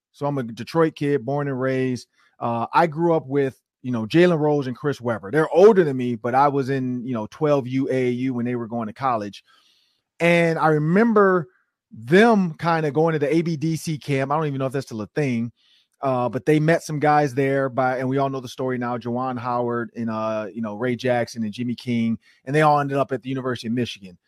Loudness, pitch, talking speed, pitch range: -22 LUFS, 135 Hz, 230 wpm, 120-150 Hz